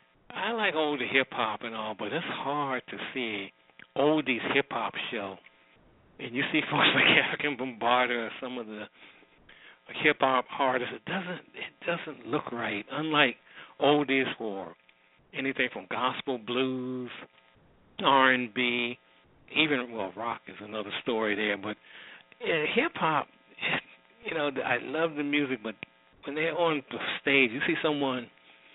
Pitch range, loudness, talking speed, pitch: 105-135 Hz, -28 LUFS, 150 wpm, 125 Hz